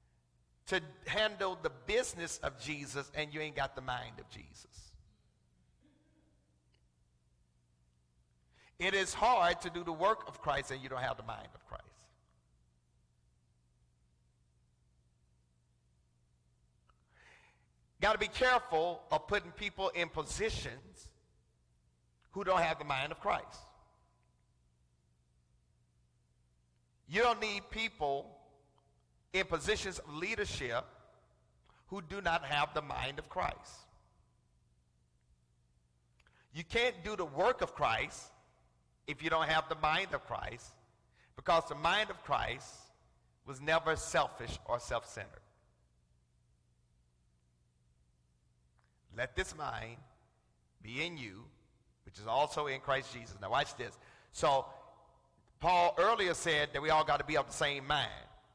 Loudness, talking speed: -35 LUFS, 120 wpm